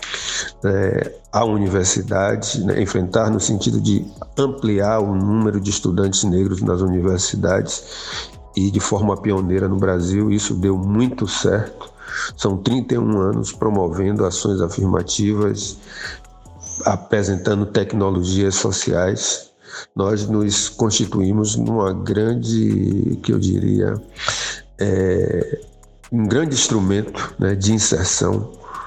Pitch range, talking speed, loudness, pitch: 95-110 Hz, 105 wpm, -19 LUFS, 100 Hz